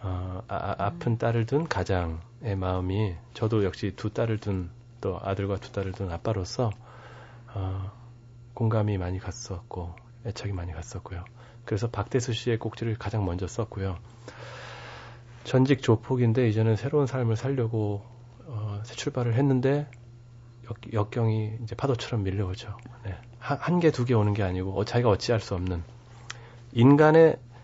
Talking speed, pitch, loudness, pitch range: 295 characters per minute, 115 Hz, -27 LUFS, 100-120 Hz